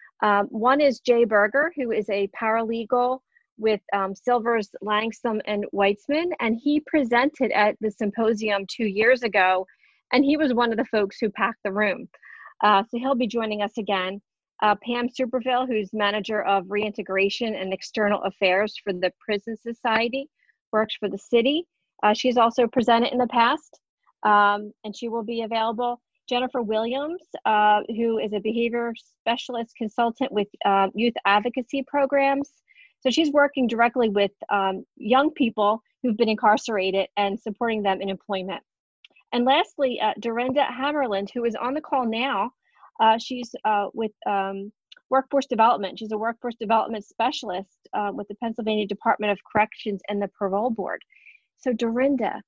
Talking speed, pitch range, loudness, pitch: 160 wpm, 205-250 Hz, -24 LUFS, 225 Hz